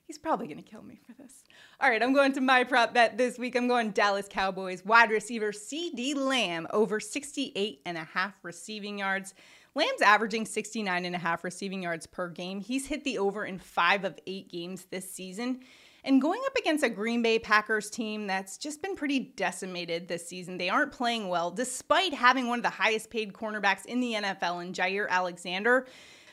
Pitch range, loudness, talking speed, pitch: 185-250 Hz, -28 LUFS, 200 wpm, 215 Hz